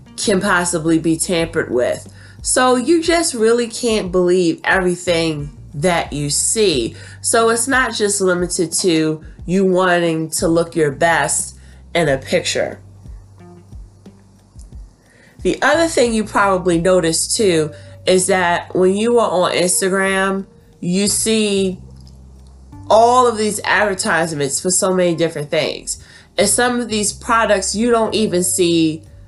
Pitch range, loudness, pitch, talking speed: 145-205 Hz, -16 LUFS, 180 Hz, 130 wpm